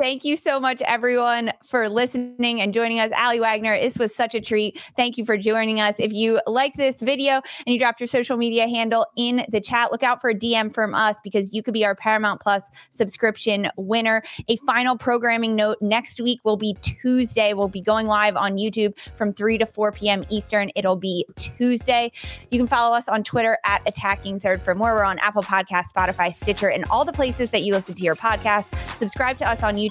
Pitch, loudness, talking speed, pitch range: 225 Hz, -21 LUFS, 220 wpm, 210-240 Hz